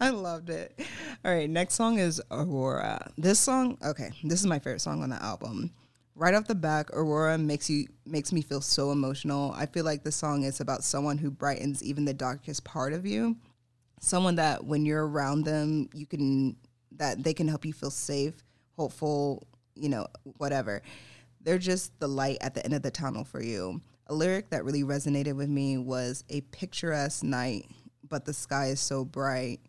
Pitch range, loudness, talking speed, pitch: 135-155 Hz, -30 LUFS, 195 wpm, 145 Hz